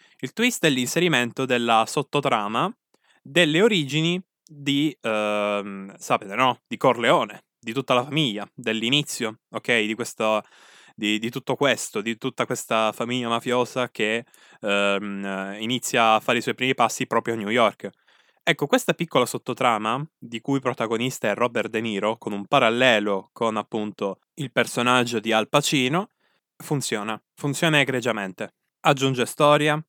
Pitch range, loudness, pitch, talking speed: 110-140 Hz, -23 LUFS, 120 Hz, 145 wpm